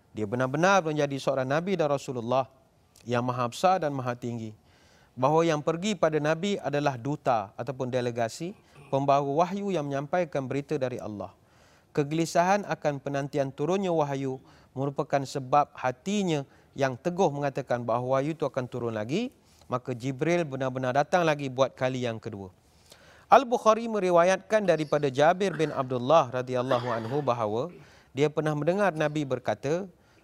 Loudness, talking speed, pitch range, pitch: -27 LUFS, 140 wpm, 125-160 Hz, 140 Hz